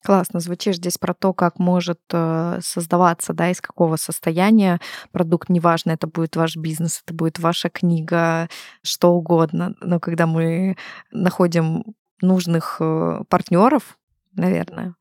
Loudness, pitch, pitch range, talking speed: -20 LUFS, 175 Hz, 165-185 Hz, 125 wpm